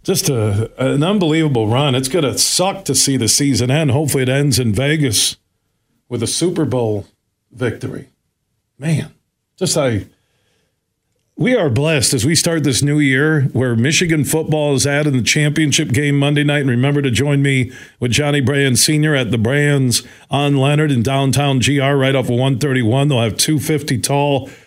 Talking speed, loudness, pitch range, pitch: 175 wpm, -15 LUFS, 125-150 Hz, 140 Hz